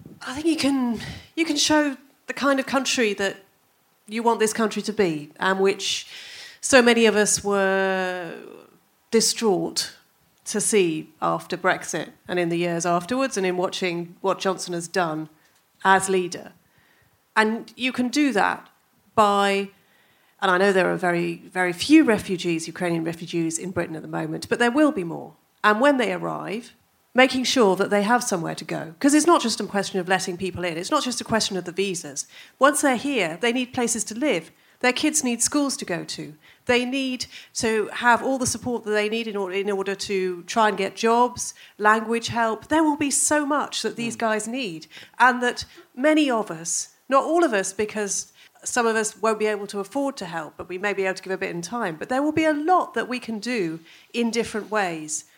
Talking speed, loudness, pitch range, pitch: 205 wpm, -23 LUFS, 185-250 Hz, 215 Hz